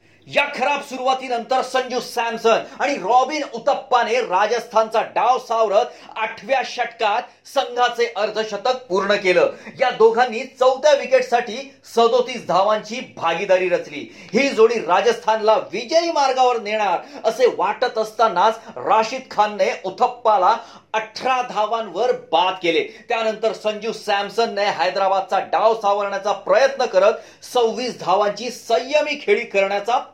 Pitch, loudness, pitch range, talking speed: 230 Hz, -19 LUFS, 210-255 Hz, 105 wpm